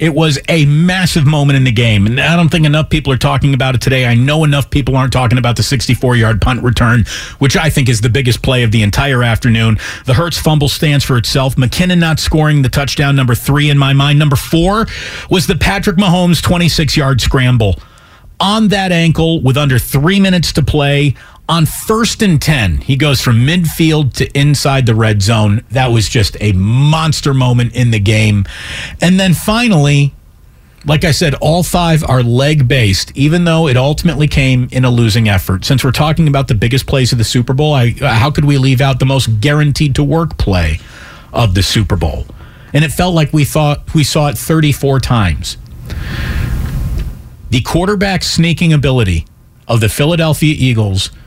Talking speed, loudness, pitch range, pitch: 190 wpm, -11 LUFS, 120-155 Hz, 140 Hz